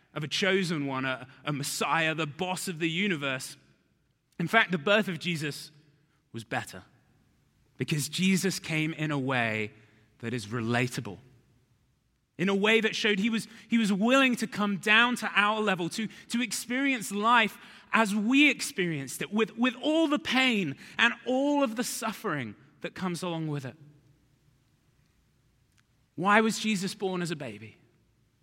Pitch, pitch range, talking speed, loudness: 180 Hz, 140-220 Hz, 160 wpm, -28 LUFS